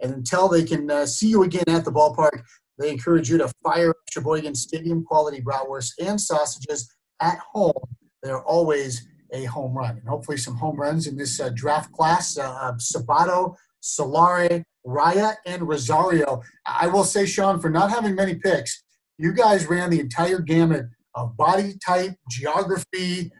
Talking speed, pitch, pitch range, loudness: 160 wpm, 160 Hz, 145-180 Hz, -22 LUFS